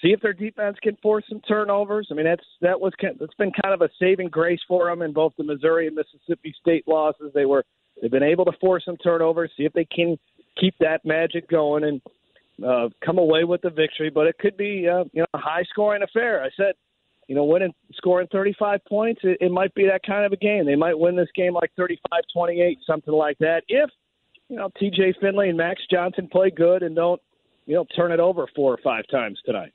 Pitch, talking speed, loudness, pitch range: 175 Hz, 235 wpm, -22 LUFS, 160-195 Hz